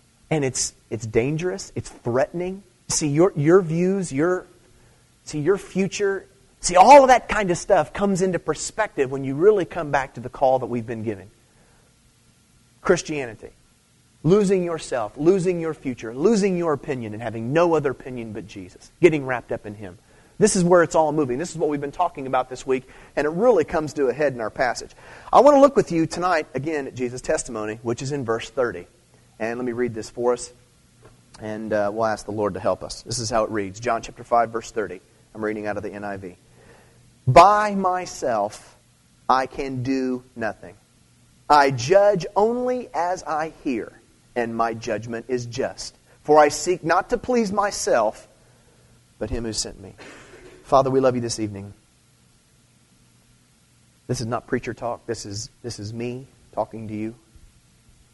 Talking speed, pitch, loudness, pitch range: 185 wpm, 130 Hz, -22 LUFS, 115-170 Hz